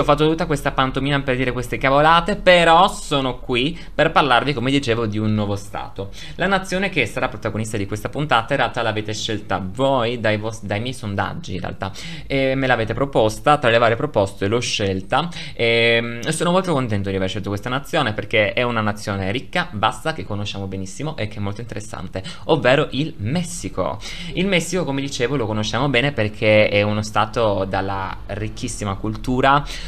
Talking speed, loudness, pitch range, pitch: 180 wpm, -20 LUFS, 105-145 Hz, 120 Hz